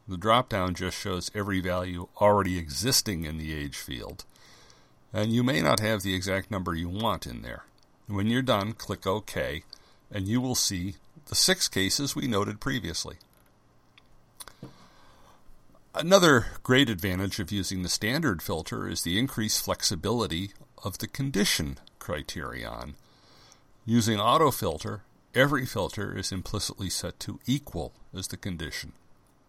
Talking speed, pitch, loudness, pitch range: 140 wpm, 100 Hz, -28 LUFS, 90-115 Hz